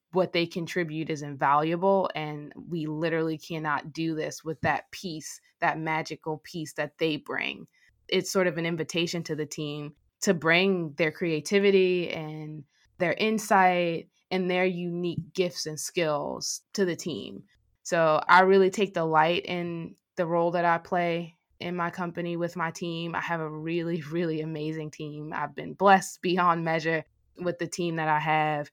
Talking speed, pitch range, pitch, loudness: 165 wpm, 155-180 Hz, 170 Hz, -27 LUFS